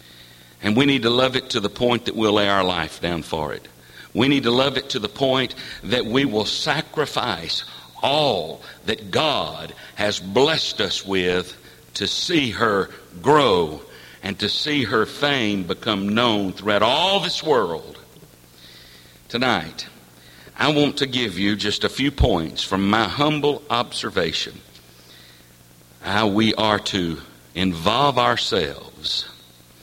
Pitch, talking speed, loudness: 105 Hz, 145 wpm, -21 LUFS